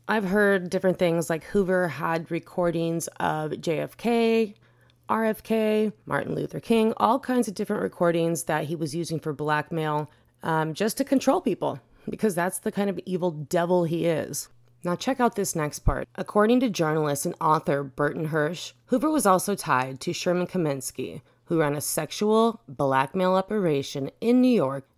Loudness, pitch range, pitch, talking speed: -25 LUFS, 150-210 Hz, 175 Hz, 165 wpm